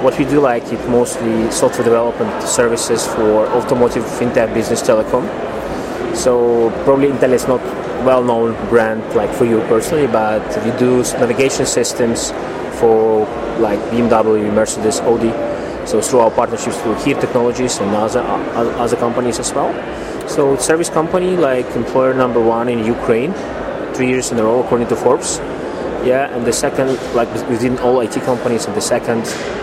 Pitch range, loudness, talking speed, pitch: 115-130 Hz, -15 LUFS, 155 wpm, 120 Hz